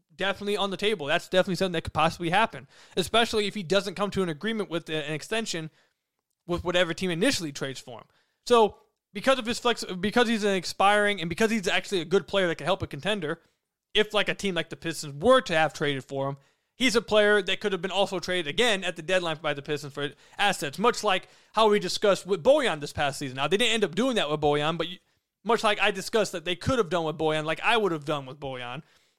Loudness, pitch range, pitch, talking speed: -26 LUFS, 155-205 Hz, 185 Hz, 245 wpm